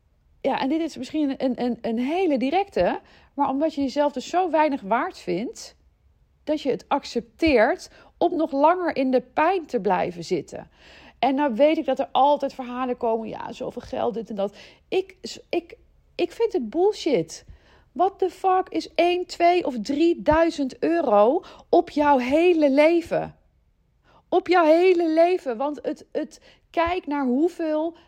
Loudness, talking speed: -23 LUFS, 160 wpm